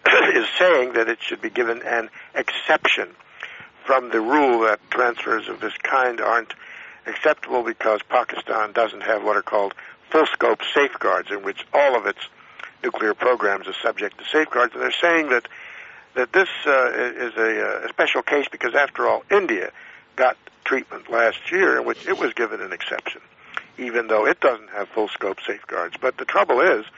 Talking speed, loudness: 170 wpm, -21 LUFS